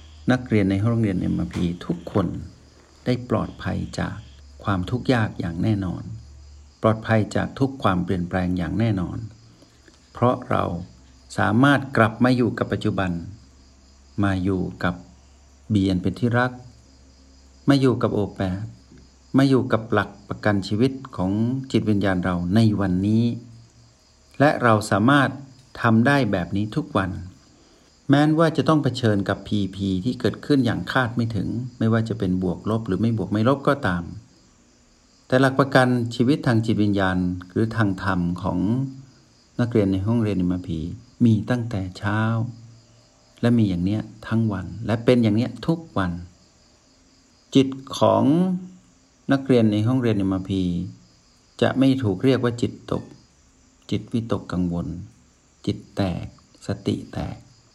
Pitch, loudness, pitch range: 105 Hz, -22 LUFS, 90-120 Hz